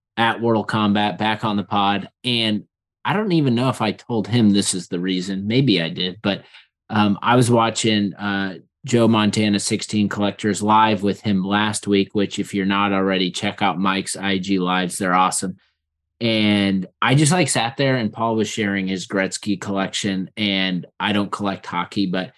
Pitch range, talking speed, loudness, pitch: 95-110 Hz, 185 wpm, -20 LUFS, 100 Hz